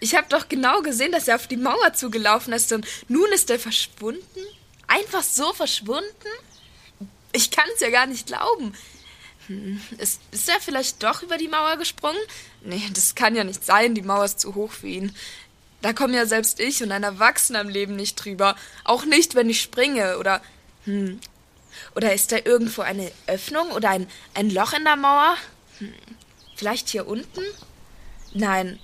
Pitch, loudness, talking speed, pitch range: 230 Hz, -21 LUFS, 180 wpm, 205-295 Hz